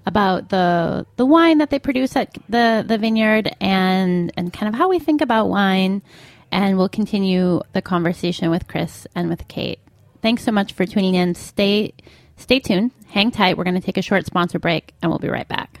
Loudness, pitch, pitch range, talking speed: -19 LUFS, 195 Hz, 180-220 Hz, 205 wpm